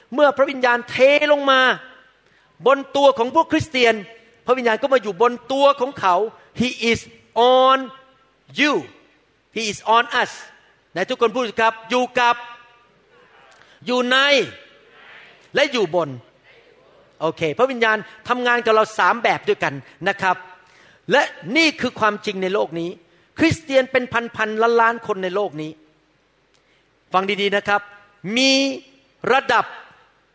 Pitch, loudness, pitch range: 235 Hz, -19 LUFS, 205-265 Hz